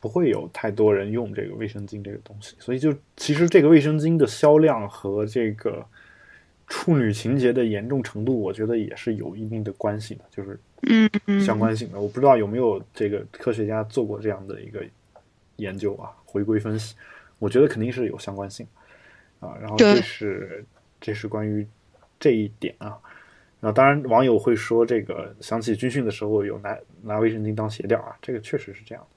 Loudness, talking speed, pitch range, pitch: -23 LUFS, 290 characters per minute, 105-125 Hz, 110 Hz